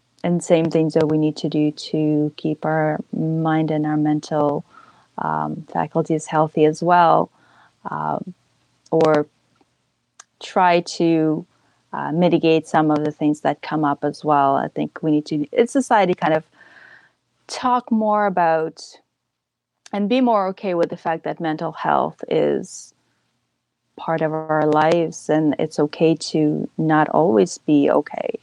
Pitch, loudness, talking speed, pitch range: 160 Hz, -20 LUFS, 150 wpm, 150-175 Hz